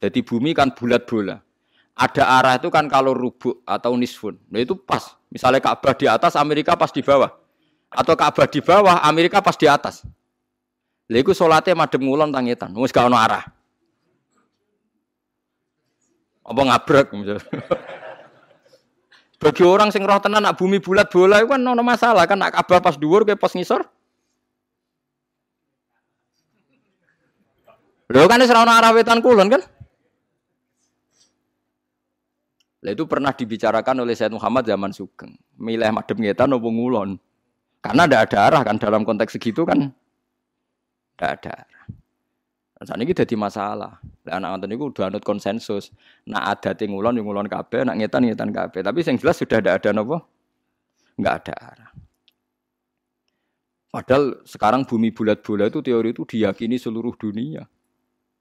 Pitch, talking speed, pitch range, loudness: 130 Hz, 145 wpm, 115-180 Hz, -18 LUFS